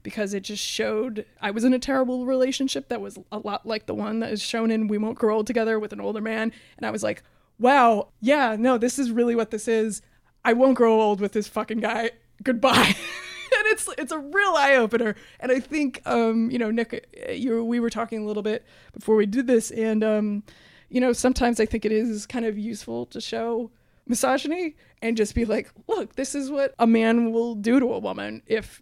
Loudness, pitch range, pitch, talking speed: -24 LUFS, 220-255 Hz, 230 Hz, 225 wpm